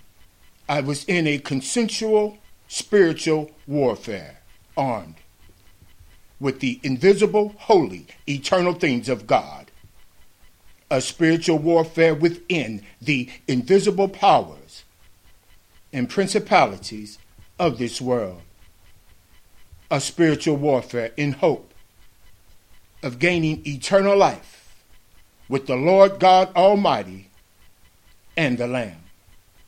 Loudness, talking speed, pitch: -20 LUFS, 90 wpm, 130 Hz